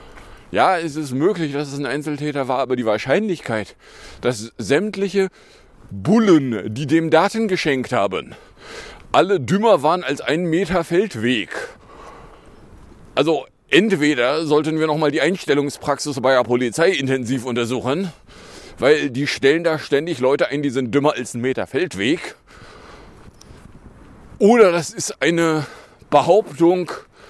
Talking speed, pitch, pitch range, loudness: 130 wpm, 150 Hz, 130-165 Hz, -19 LUFS